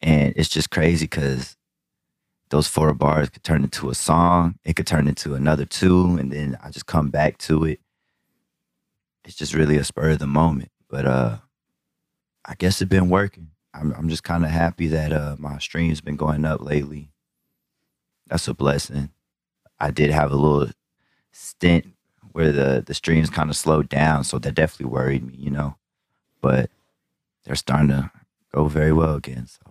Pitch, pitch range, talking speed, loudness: 75 Hz, 70-80 Hz, 180 wpm, -21 LUFS